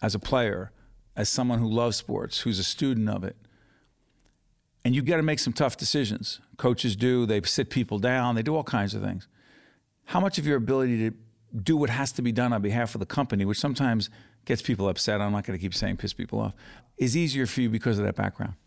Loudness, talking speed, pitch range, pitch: -27 LUFS, 230 wpm, 105-130 Hz, 115 Hz